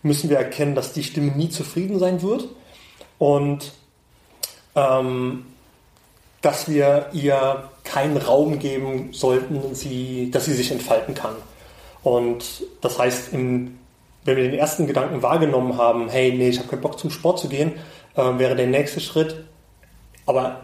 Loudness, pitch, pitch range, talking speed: -22 LUFS, 140 Hz, 130-155 Hz, 150 wpm